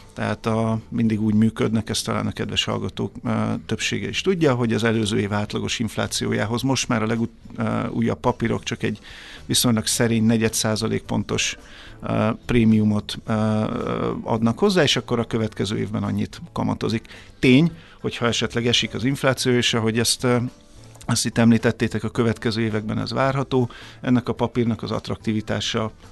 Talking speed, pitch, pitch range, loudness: 145 wpm, 115 Hz, 110-120 Hz, -22 LUFS